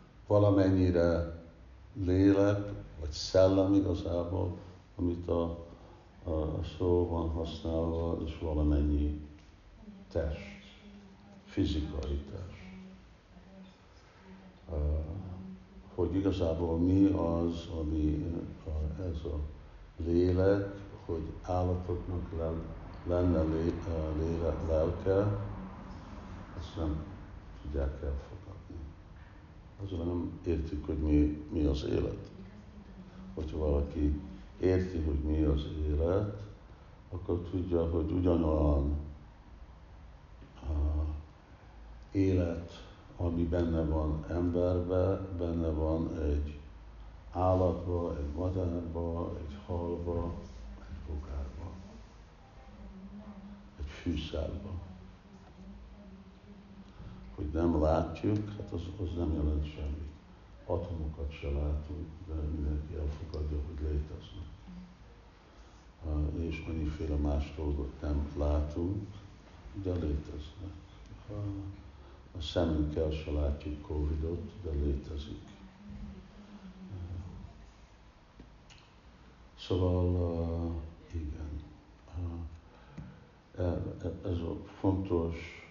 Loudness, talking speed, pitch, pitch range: -33 LUFS, 75 wpm, 85 Hz, 75-95 Hz